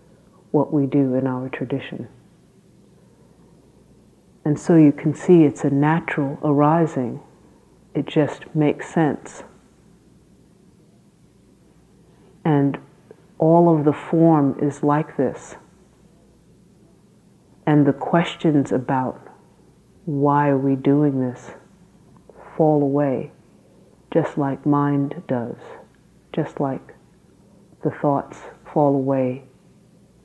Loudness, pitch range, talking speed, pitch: -20 LUFS, 140-155 Hz, 95 wpm, 145 Hz